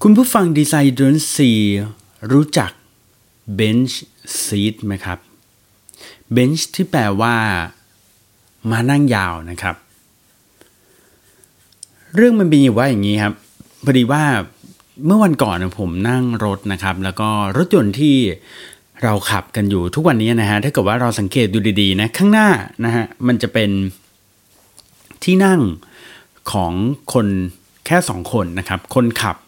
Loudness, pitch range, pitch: -16 LUFS, 100-135 Hz, 110 Hz